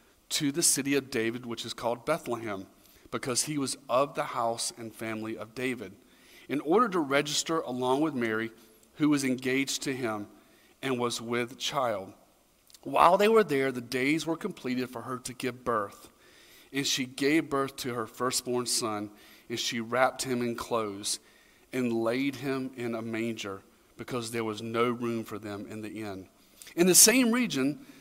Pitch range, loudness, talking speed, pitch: 115-140 Hz, -29 LUFS, 175 wpm, 125 Hz